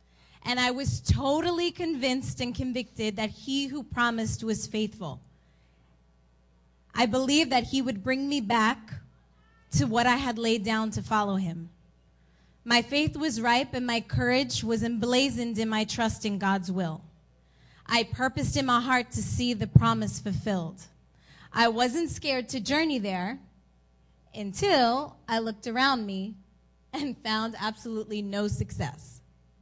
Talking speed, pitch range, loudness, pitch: 145 wpm, 160-250 Hz, -28 LUFS, 220 Hz